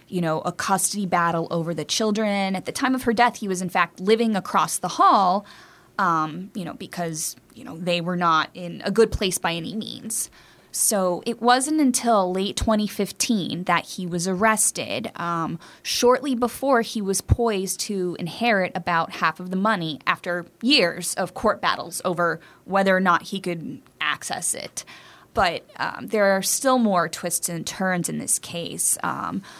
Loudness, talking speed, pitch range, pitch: -23 LUFS, 175 wpm, 175-220 Hz, 190 Hz